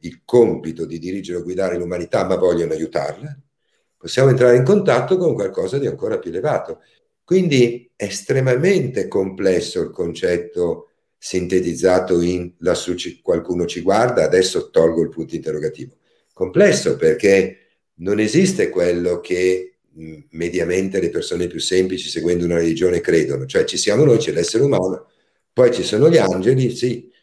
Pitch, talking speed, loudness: 125 Hz, 145 wpm, -18 LUFS